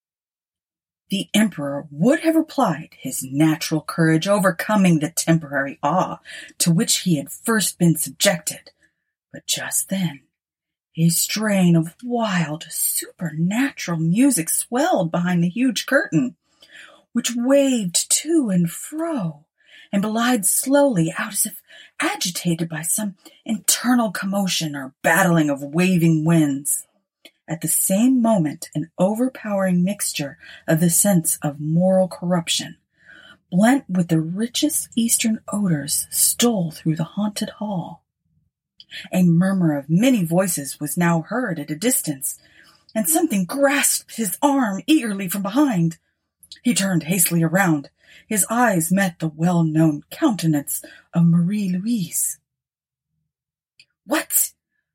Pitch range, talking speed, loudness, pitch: 160-225 Hz, 120 wpm, -20 LUFS, 180 Hz